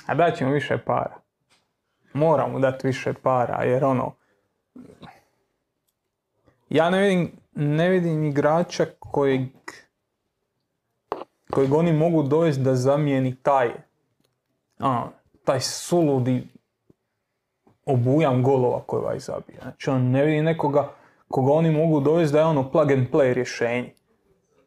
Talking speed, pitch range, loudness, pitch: 120 wpm, 130-160 Hz, -22 LUFS, 145 Hz